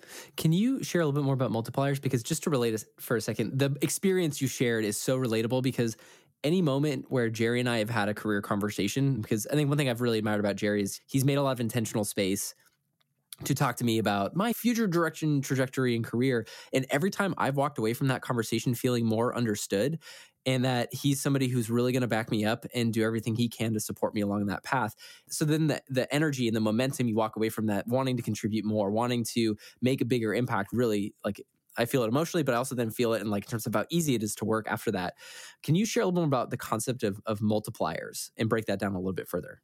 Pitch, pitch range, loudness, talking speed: 120 Hz, 110-135 Hz, -29 LUFS, 250 wpm